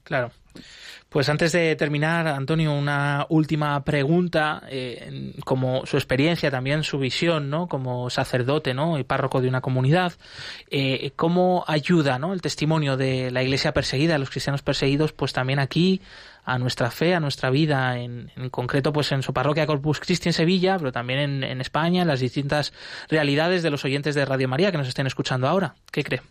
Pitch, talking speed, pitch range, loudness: 145 Hz, 185 wpm, 130-155 Hz, -23 LUFS